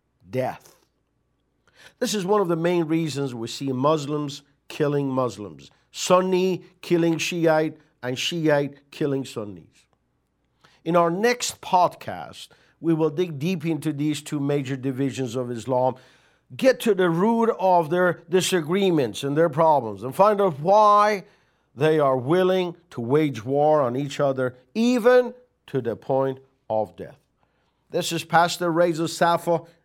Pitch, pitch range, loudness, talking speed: 160 Hz, 135-180 Hz, -22 LUFS, 140 wpm